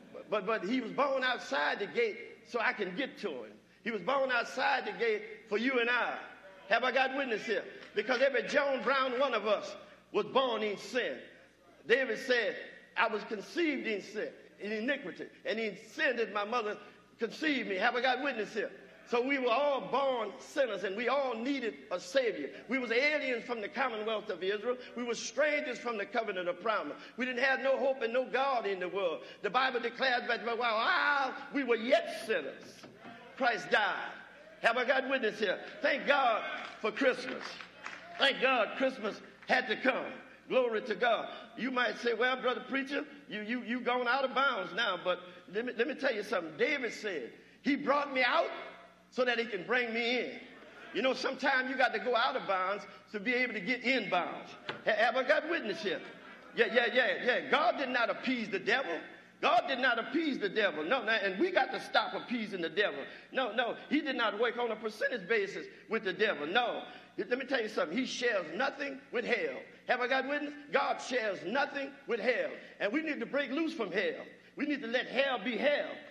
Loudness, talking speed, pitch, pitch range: -32 LUFS, 205 wpm, 255 Hz, 230-285 Hz